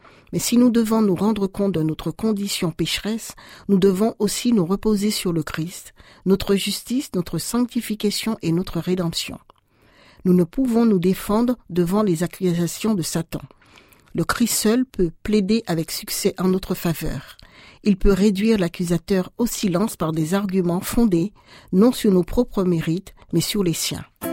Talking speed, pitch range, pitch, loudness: 160 wpm, 175-215 Hz, 195 Hz, -21 LUFS